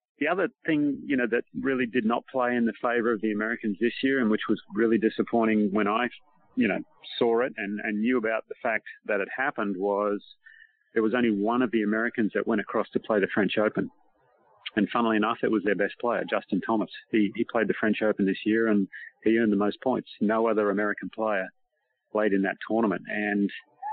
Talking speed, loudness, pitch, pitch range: 220 wpm, -27 LUFS, 110 Hz, 105-120 Hz